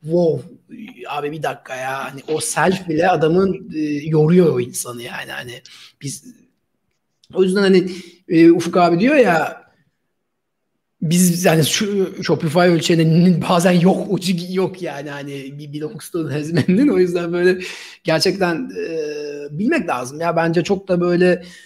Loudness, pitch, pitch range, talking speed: -17 LUFS, 170 Hz, 155-185 Hz, 140 wpm